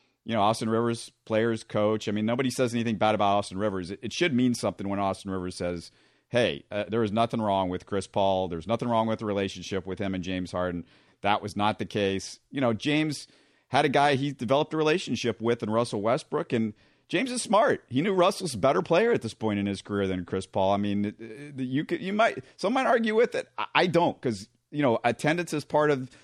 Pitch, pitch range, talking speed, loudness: 110 Hz, 100-130 Hz, 235 wpm, -27 LUFS